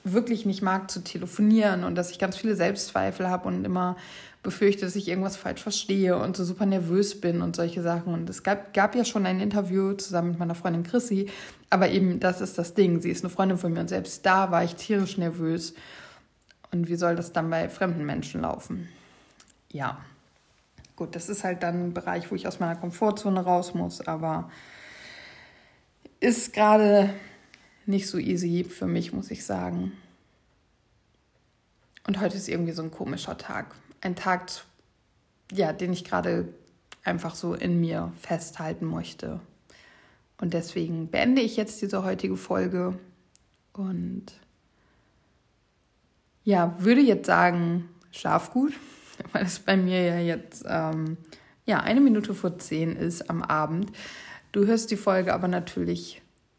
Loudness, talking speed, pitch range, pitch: -27 LUFS, 160 wpm, 170-200 Hz, 185 Hz